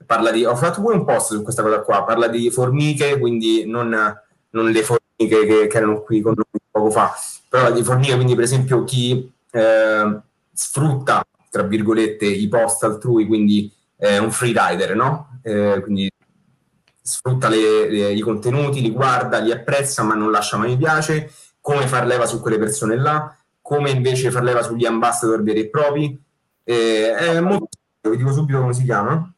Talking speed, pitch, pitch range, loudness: 180 wpm, 120 Hz, 110-135 Hz, -18 LUFS